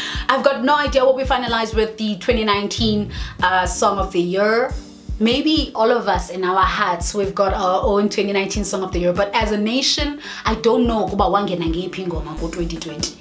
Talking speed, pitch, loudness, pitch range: 190 wpm, 205 Hz, -19 LUFS, 180-230 Hz